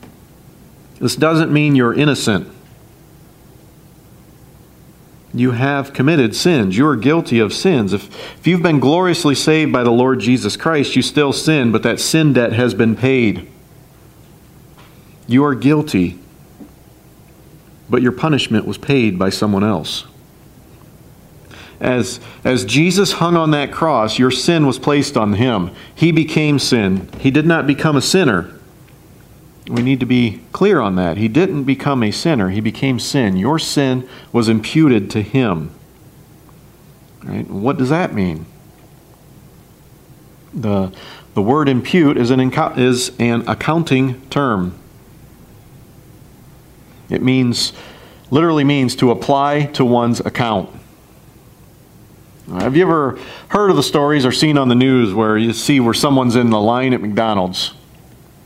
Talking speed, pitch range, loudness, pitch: 140 wpm, 115-145 Hz, -15 LUFS, 130 Hz